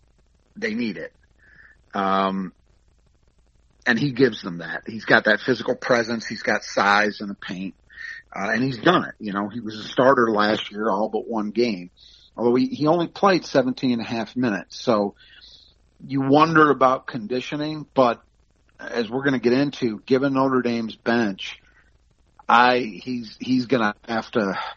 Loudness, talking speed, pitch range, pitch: -22 LUFS, 165 wpm, 105-130 Hz, 120 Hz